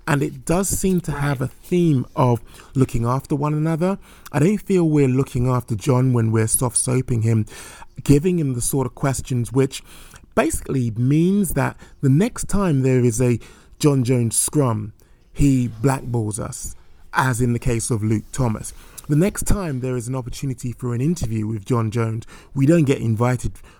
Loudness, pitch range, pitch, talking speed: -20 LUFS, 120-145 Hz, 130 Hz, 180 wpm